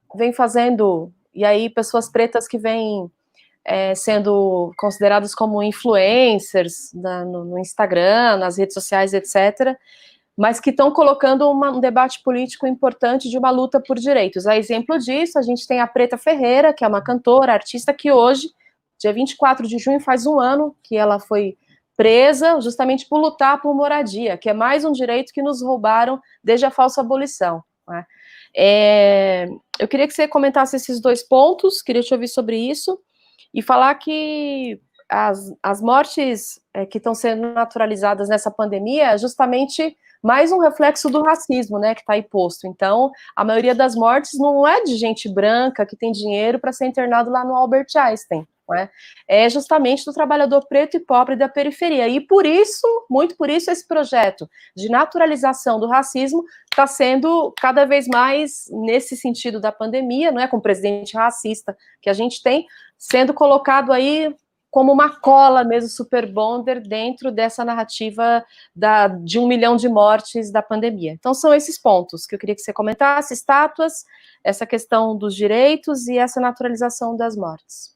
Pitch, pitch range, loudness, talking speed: 250 Hz, 215-280 Hz, -17 LUFS, 170 wpm